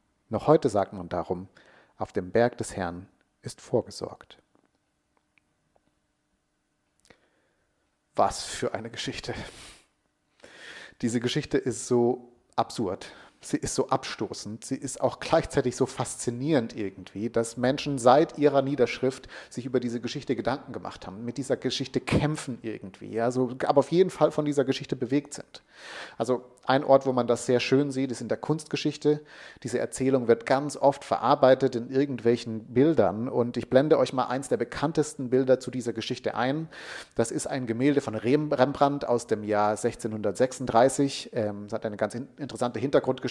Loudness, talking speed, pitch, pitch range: -27 LUFS, 150 wpm, 130 Hz, 115-140 Hz